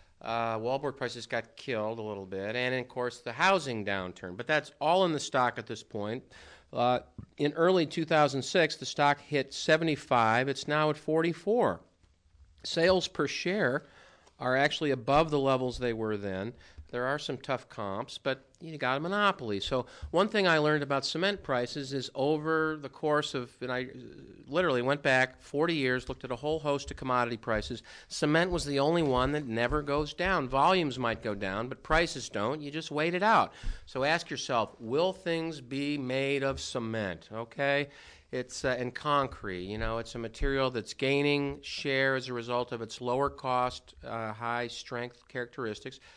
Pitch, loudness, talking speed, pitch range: 130 Hz, -30 LUFS, 180 wpm, 120-150 Hz